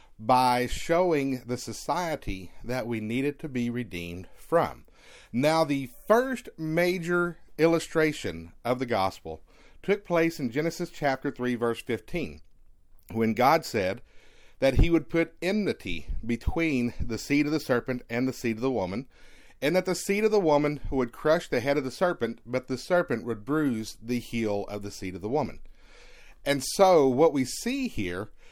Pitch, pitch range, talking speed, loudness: 130 Hz, 115-165 Hz, 170 wpm, -27 LUFS